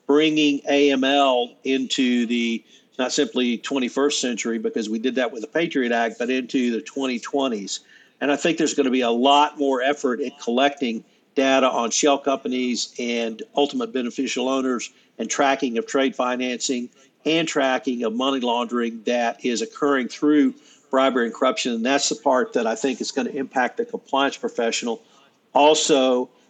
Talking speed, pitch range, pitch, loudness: 165 wpm, 120-140 Hz, 130 Hz, -22 LUFS